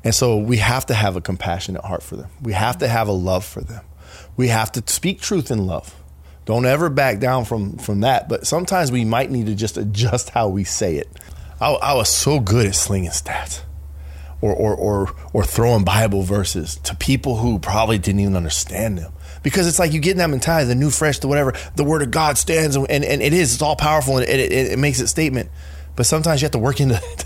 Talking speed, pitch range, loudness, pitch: 240 wpm, 95-140 Hz, -18 LUFS, 115 Hz